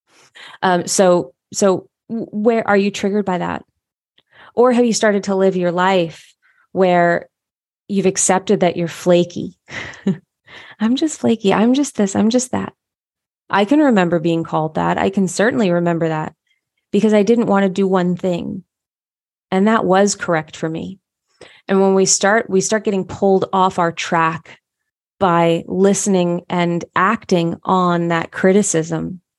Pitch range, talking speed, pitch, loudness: 175-205 Hz, 155 wpm, 190 Hz, -16 LUFS